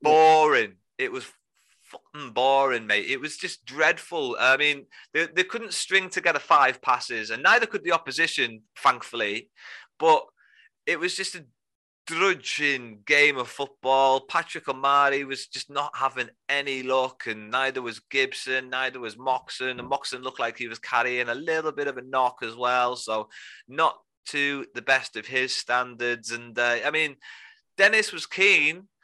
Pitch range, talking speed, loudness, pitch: 125-155 Hz, 165 wpm, -24 LUFS, 135 Hz